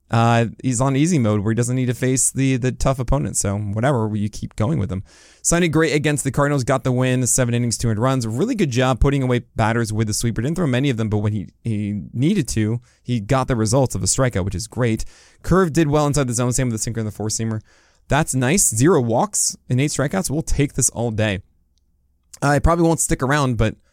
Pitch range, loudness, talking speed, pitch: 110-140 Hz, -19 LUFS, 245 wpm, 125 Hz